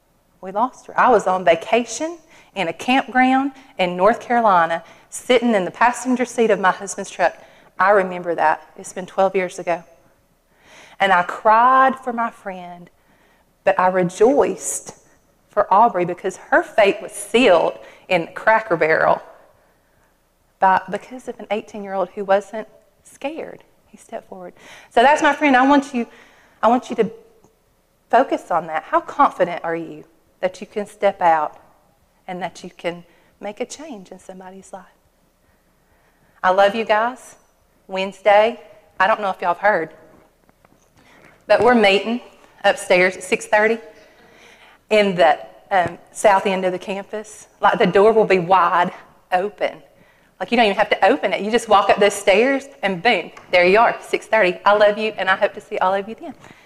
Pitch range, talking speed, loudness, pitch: 185-230 Hz, 175 wpm, -18 LUFS, 200 Hz